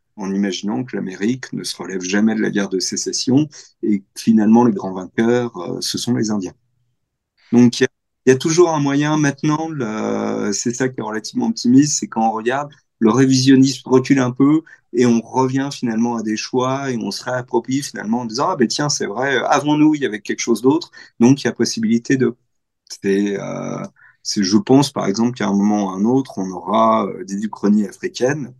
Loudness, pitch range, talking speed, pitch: -18 LUFS, 110-140 Hz, 210 wpm, 120 Hz